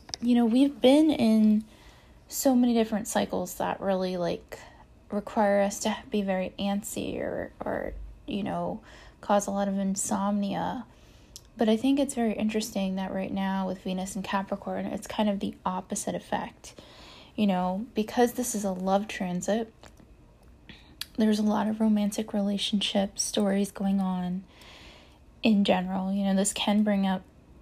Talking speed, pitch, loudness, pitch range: 155 wpm, 205 Hz, -28 LUFS, 195-220 Hz